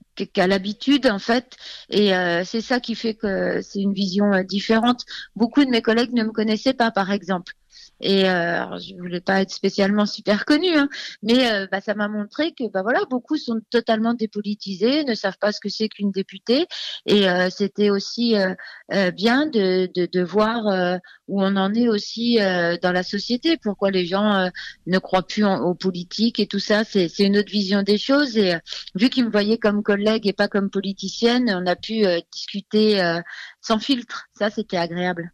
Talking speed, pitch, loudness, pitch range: 205 wpm, 205 Hz, -21 LUFS, 190-230 Hz